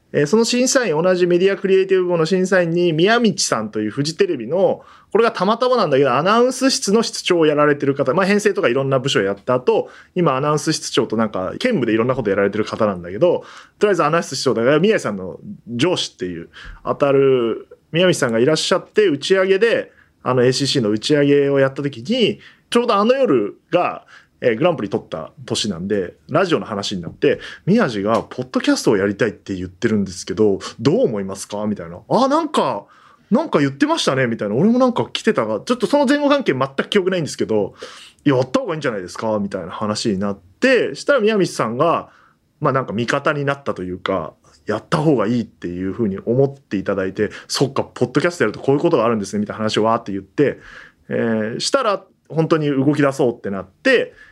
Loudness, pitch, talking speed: -18 LUFS, 145 Hz, 465 characters per minute